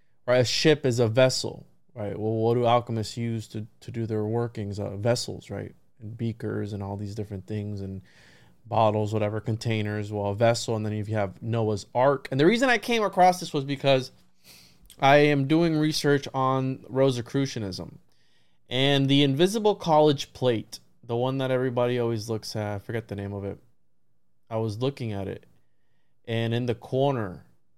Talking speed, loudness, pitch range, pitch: 175 wpm, -25 LUFS, 105-130 Hz, 115 Hz